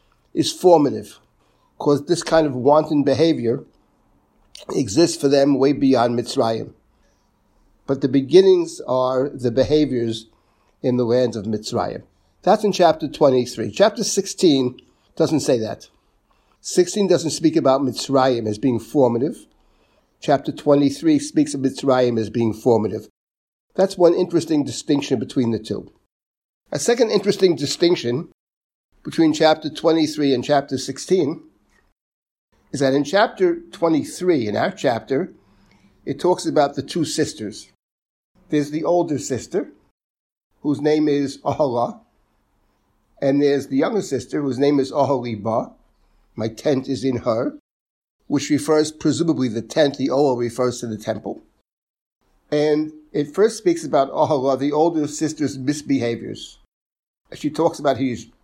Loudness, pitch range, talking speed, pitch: -20 LUFS, 125-160 Hz, 130 wpm, 140 Hz